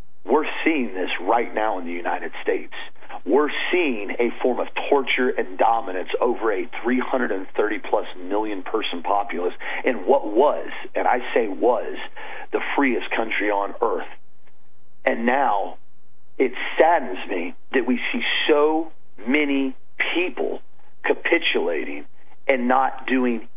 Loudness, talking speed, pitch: -22 LUFS, 130 wpm, 350 Hz